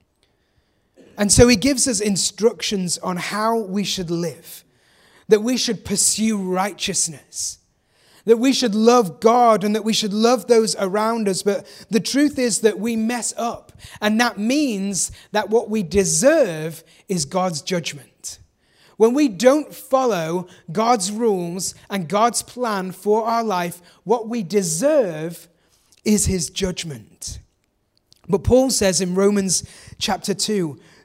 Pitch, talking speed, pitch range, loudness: 210 Hz, 140 wpm, 185-235 Hz, -19 LUFS